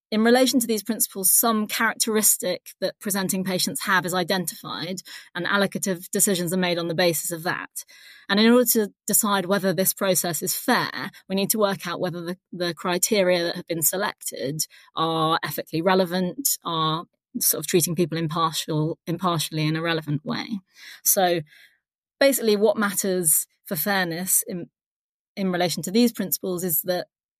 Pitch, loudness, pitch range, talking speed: 185 Hz, -22 LUFS, 170-205 Hz, 160 wpm